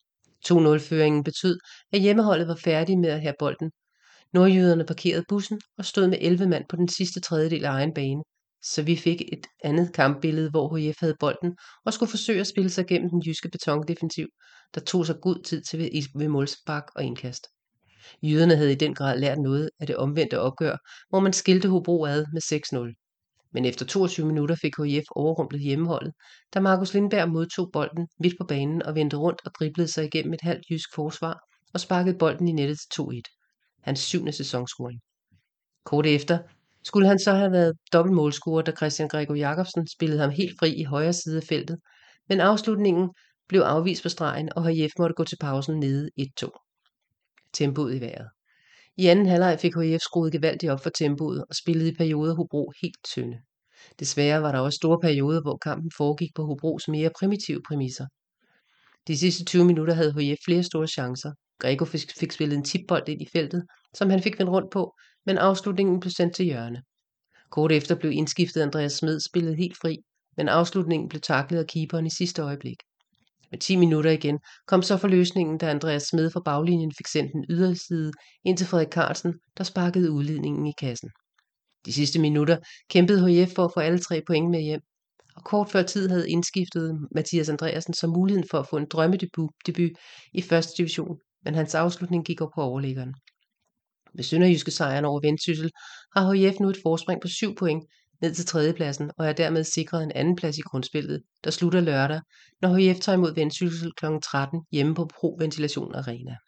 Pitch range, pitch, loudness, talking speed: 150-175 Hz, 165 Hz, -25 LUFS, 185 wpm